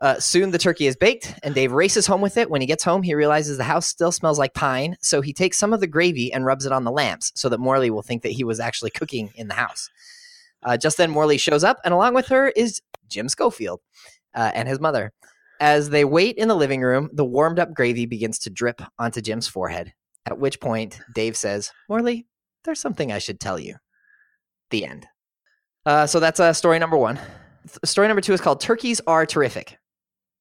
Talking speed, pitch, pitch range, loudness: 225 wpm, 155 Hz, 130-200 Hz, -21 LUFS